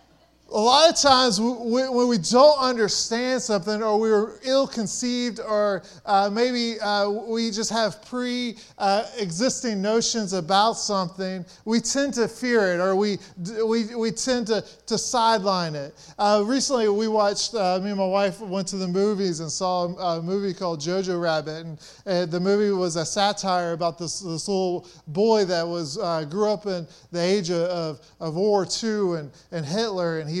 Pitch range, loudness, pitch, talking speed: 180-225 Hz, -23 LUFS, 200 Hz, 175 wpm